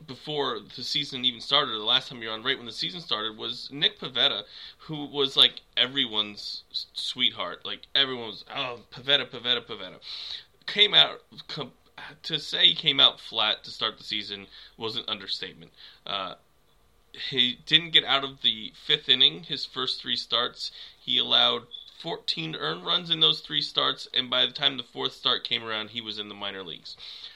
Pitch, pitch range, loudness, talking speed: 125 Hz, 110-145 Hz, -24 LUFS, 180 wpm